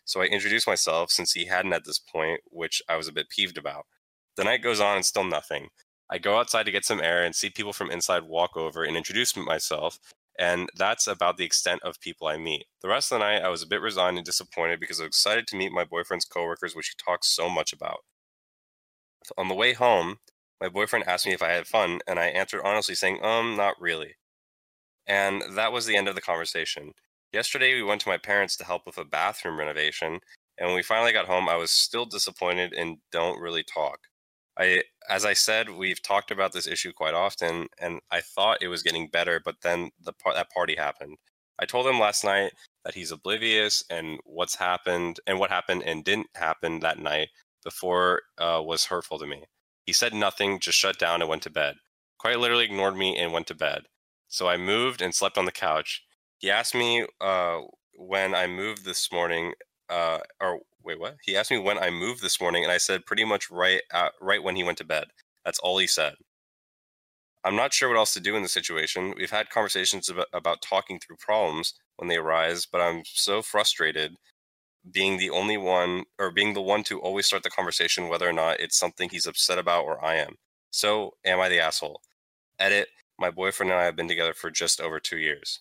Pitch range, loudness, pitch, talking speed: 85-100 Hz, -26 LUFS, 90 Hz, 220 wpm